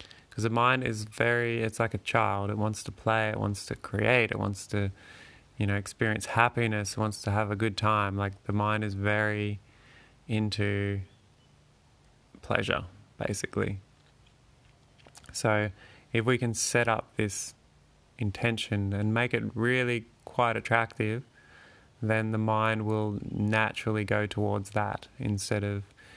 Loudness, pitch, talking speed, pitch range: -29 LUFS, 110 Hz, 145 wpm, 105-120 Hz